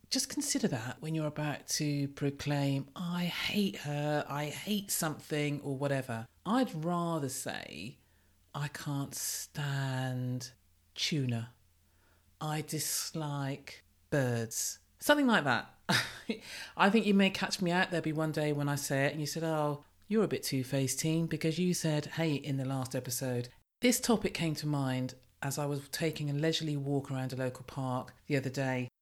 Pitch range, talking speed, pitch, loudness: 130-160 Hz, 165 wpm, 145 Hz, -33 LUFS